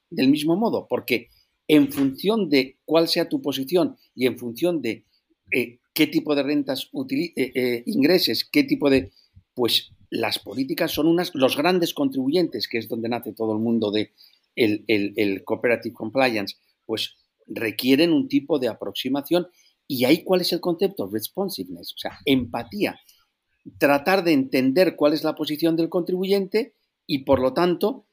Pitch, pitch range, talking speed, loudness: 145 Hz, 120-180 Hz, 165 wpm, -23 LUFS